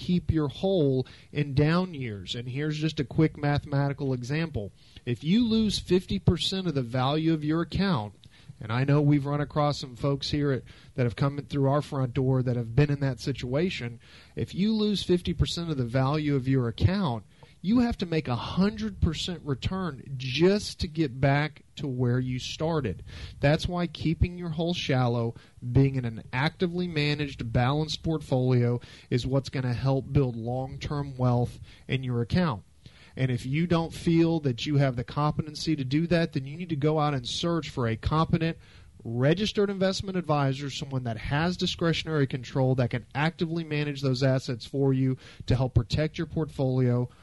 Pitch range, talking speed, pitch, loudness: 125-160 Hz, 180 wpm, 140 Hz, -28 LUFS